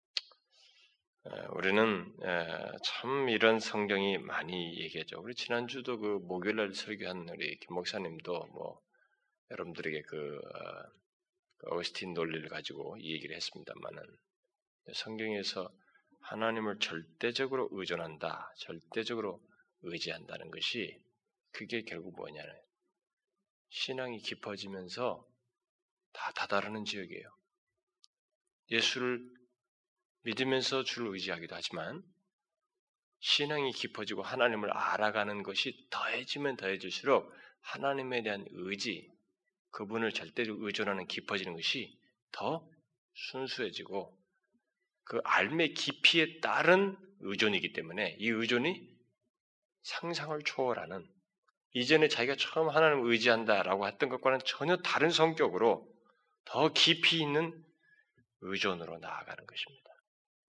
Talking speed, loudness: 265 characters per minute, -33 LUFS